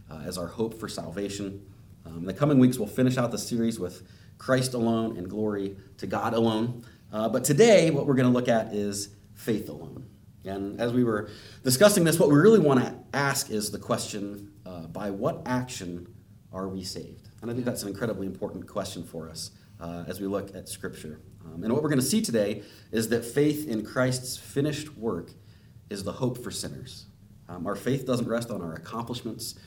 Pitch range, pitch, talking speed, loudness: 100-125 Hz, 105 Hz, 205 wpm, -27 LUFS